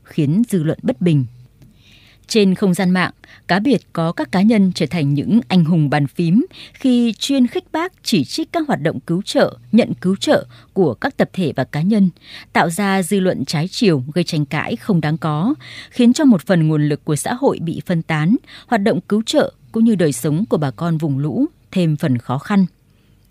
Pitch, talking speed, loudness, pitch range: 175 Hz, 215 wpm, -17 LUFS, 150-220 Hz